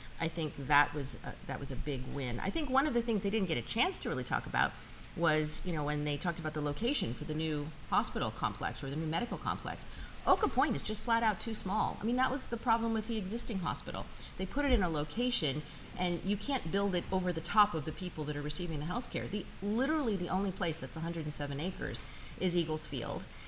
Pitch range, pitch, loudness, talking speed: 150-215 Hz, 175 Hz, -34 LUFS, 245 wpm